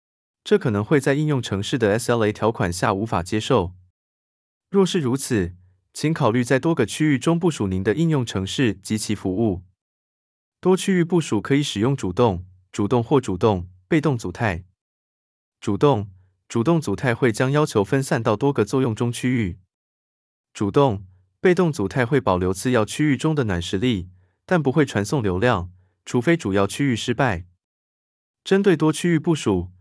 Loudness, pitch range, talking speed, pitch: -21 LUFS, 95-145 Hz, 250 characters per minute, 115 Hz